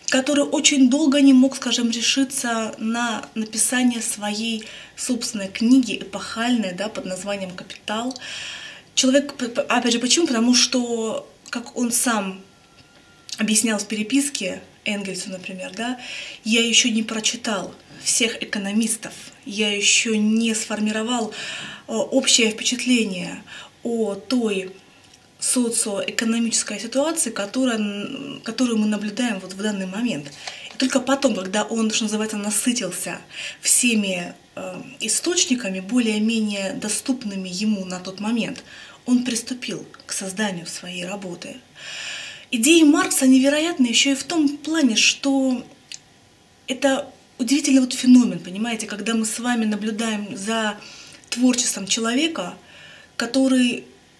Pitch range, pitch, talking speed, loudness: 210-255 Hz, 230 Hz, 115 wpm, -21 LUFS